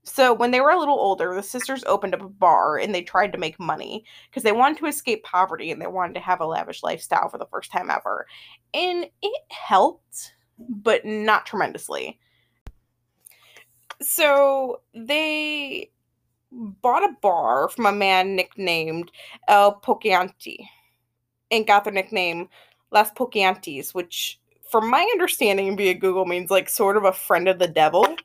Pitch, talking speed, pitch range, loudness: 205 Hz, 160 wpm, 185-265 Hz, -21 LUFS